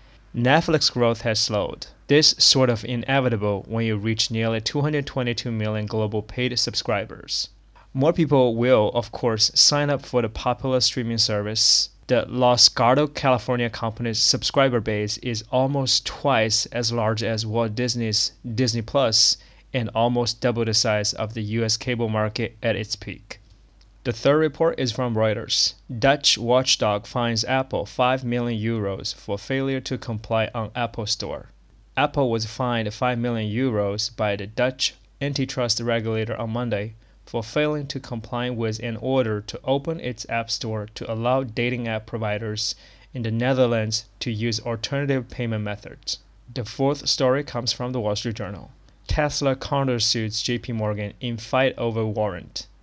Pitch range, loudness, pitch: 110-130 Hz, -22 LUFS, 120 Hz